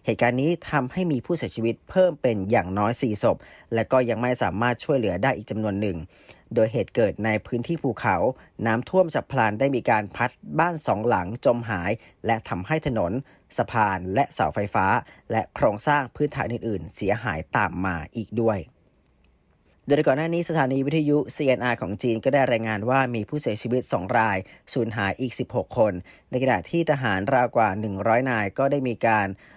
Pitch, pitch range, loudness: 120 Hz, 105-135 Hz, -24 LUFS